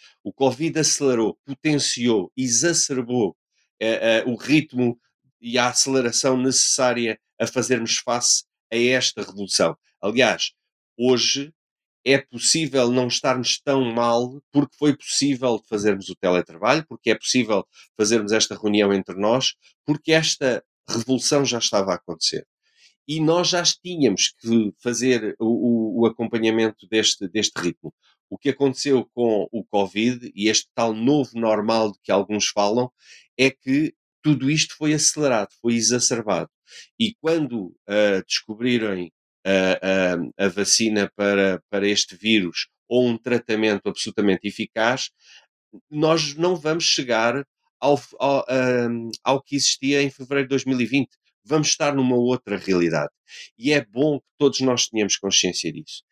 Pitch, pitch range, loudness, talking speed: 120 Hz, 110-140 Hz, -21 LUFS, 140 wpm